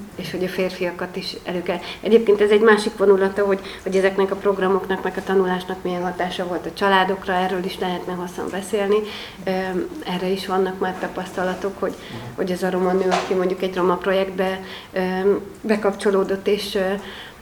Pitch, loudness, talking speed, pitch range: 190 Hz, -21 LUFS, 165 wpm, 185-195 Hz